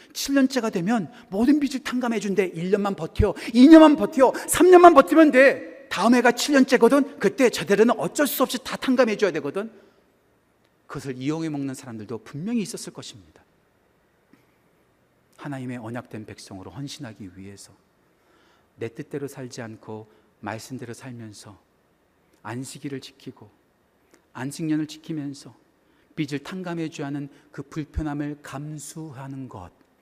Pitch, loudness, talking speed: 150 Hz, -20 LUFS, 290 characters per minute